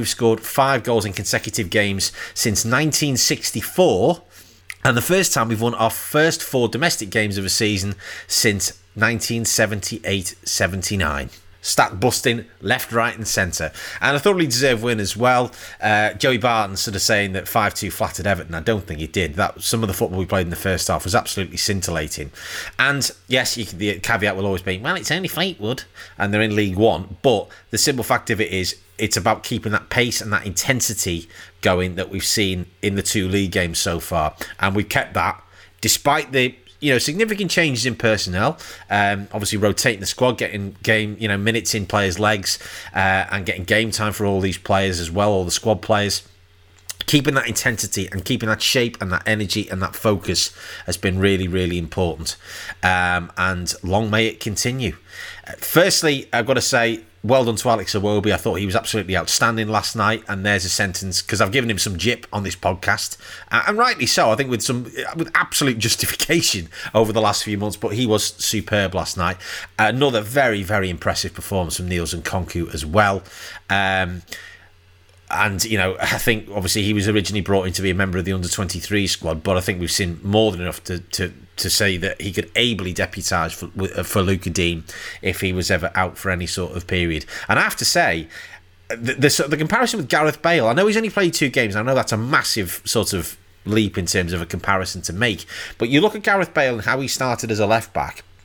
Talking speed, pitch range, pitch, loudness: 205 wpm, 95-115 Hz, 105 Hz, -20 LUFS